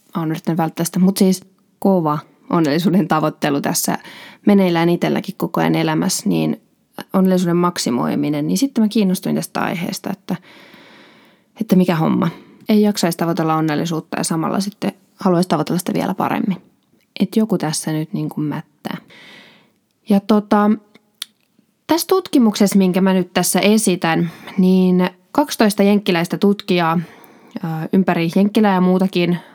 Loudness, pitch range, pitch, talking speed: -17 LUFS, 170-205 Hz, 185 Hz, 125 wpm